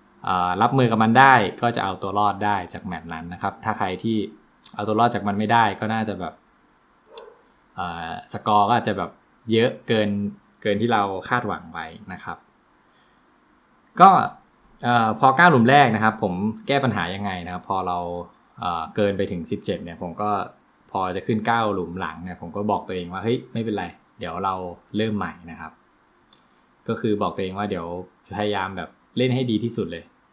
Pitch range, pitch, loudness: 95-110 Hz, 105 Hz, -22 LUFS